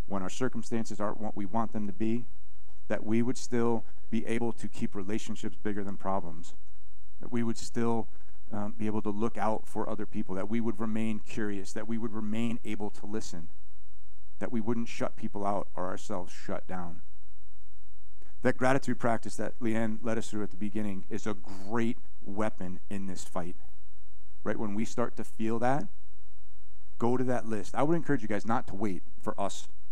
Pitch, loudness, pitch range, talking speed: 105 Hz, -34 LUFS, 95-115 Hz, 195 wpm